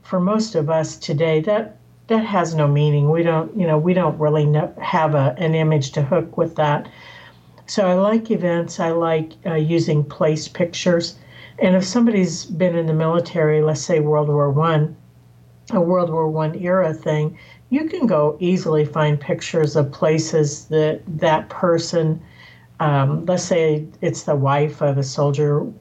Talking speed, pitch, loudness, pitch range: 170 wpm, 160 Hz, -19 LUFS, 150-175 Hz